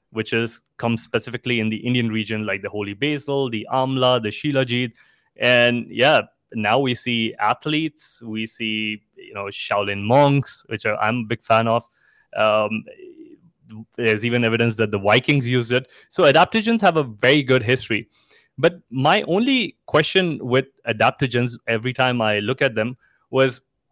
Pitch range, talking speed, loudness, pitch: 110-135 Hz, 160 wpm, -20 LUFS, 125 Hz